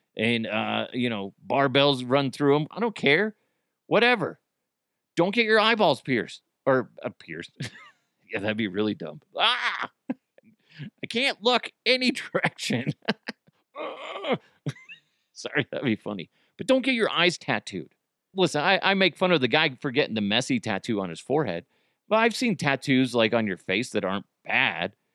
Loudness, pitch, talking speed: -25 LUFS, 145 Hz, 165 wpm